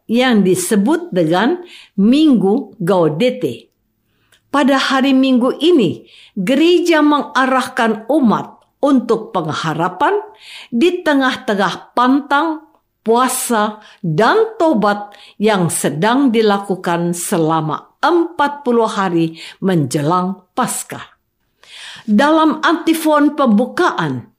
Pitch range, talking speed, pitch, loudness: 195-290 Hz, 75 wpm, 240 Hz, -15 LUFS